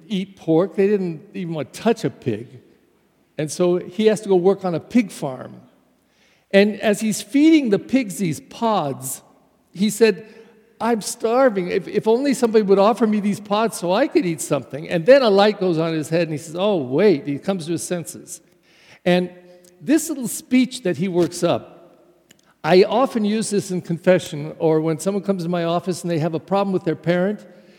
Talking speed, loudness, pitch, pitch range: 205 wpm, -20 LUFS, 185 Hz, 170-215 Hz